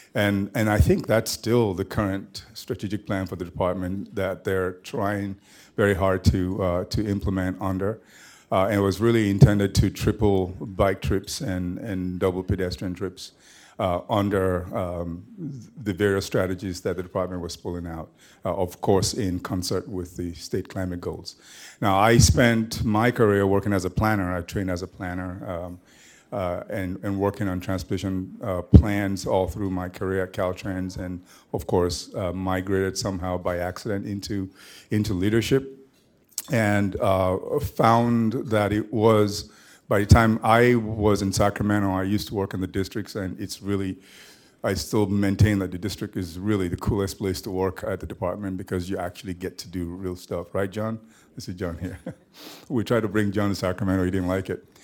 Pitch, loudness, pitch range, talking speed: 95 Hz, -25 LUFS, 95-105 Hz, 180 wpm